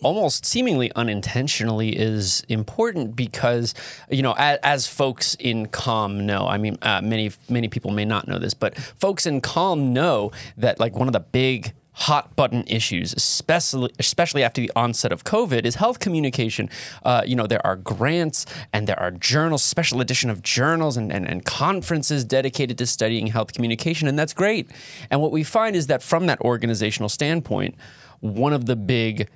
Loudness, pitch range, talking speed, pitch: -22 LUFS, 110-145 Hz, 180 wpm, 125 Hz